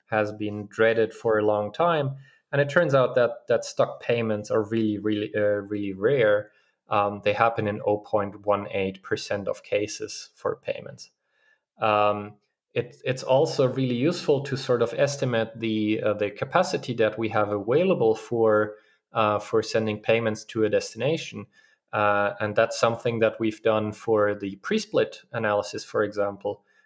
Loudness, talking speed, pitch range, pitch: -25 LUFS, 155 wpm, 105-125 Hz, 110 Hz